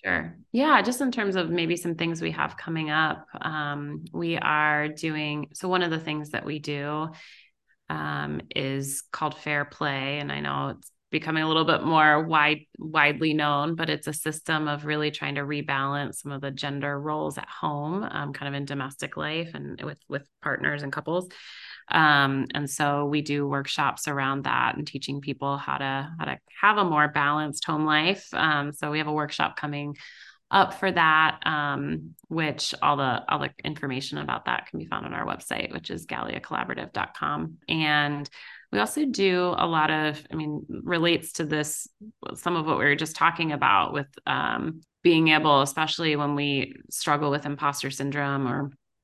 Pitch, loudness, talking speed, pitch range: 150 Hz, -26 LUFS, 185 wpm, 140-160 Hz